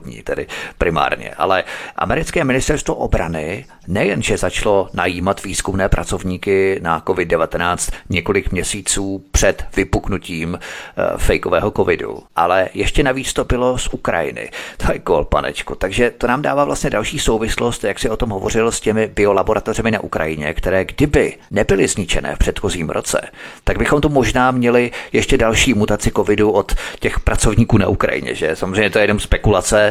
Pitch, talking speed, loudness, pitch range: 105 Hz, 150 wpm, -17 LUFS, 95-120 Hz